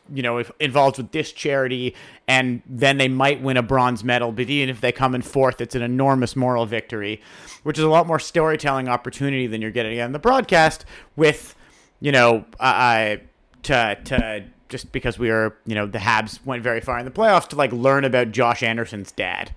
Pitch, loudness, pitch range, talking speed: 125 Hz, -20 LUFS, 120-140 Hz, 205 wpm